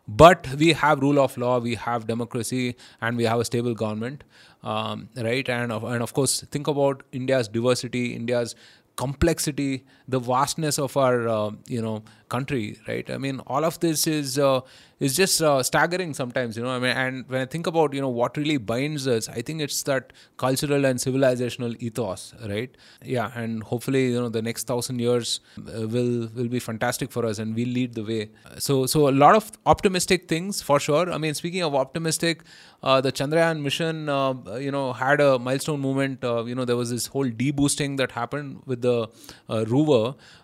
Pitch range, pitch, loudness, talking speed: 120-145 Hz, 130 Hz, -24 LUFS, 195 wpm